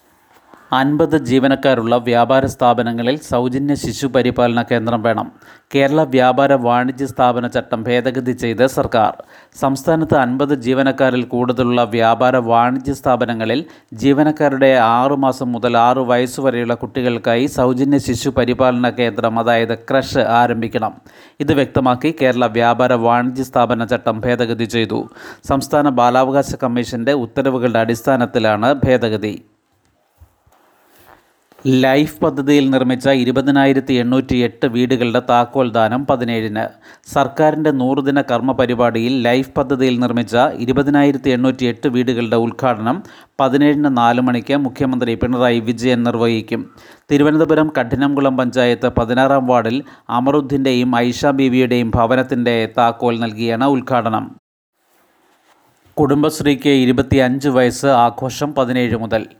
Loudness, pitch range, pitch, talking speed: -15 LUFS, 120-135 Hz, 125 Hz, 100 wpm